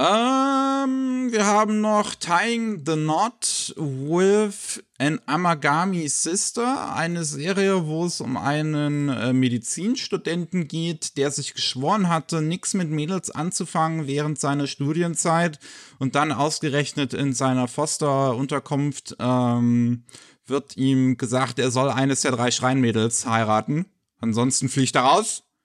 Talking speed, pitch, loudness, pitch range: 120 wpm, 150 Hz, -22 LUFS, 135-175 Hz